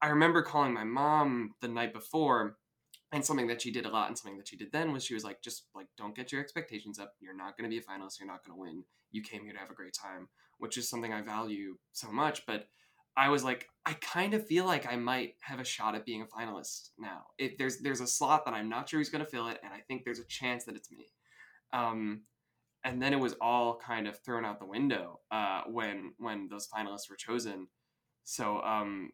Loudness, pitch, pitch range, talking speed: -35 LUFS, 120 Hz, 110-135 Hz, 250 wpm